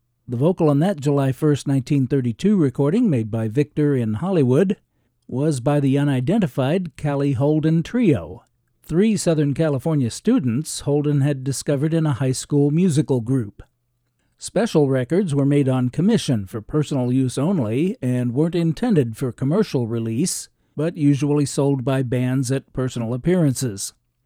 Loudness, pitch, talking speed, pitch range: -20 LUFS, 140 Hz, 140 wpm, 130-155 Hz